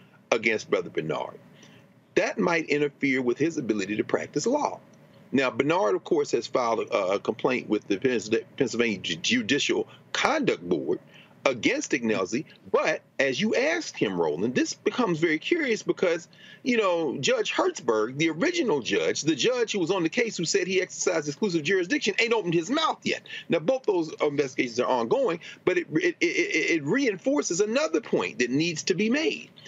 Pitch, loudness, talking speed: 230 Hz, -26 LUFS, 170 wpm